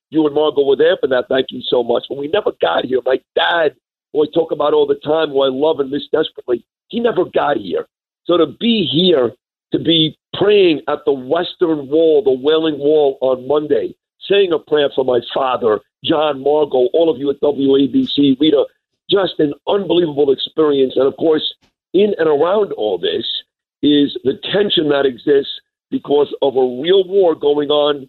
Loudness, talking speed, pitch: -15 LUFS, 190 wpm, 160 Hz